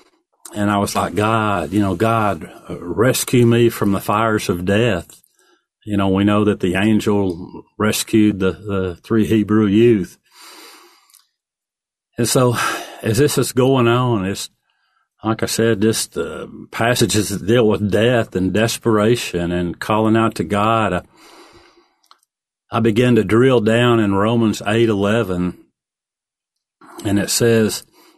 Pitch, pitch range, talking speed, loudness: 110 Hz, 100-115 Hz, 140 wpm, -17 LUFS